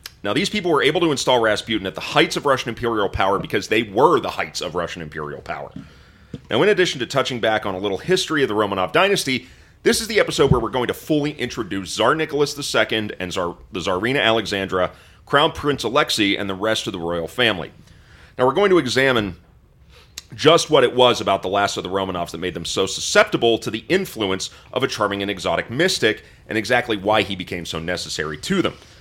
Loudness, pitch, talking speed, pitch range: -20 LUFS, 110 Hz, 215 wpm, 90-130 Hz